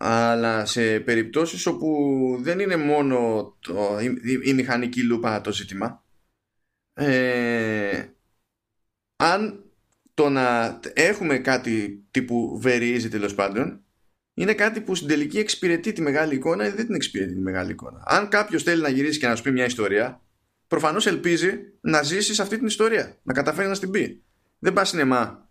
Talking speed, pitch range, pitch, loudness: 160 wpm, 115-165 Hz, 130 Hz, -23 LUFS